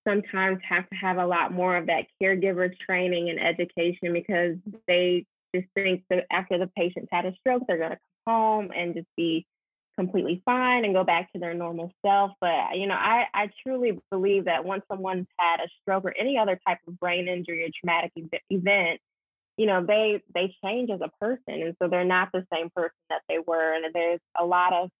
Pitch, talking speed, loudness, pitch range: 180 Hz, 210 wpm, -26 LUFS, 170-195 Hz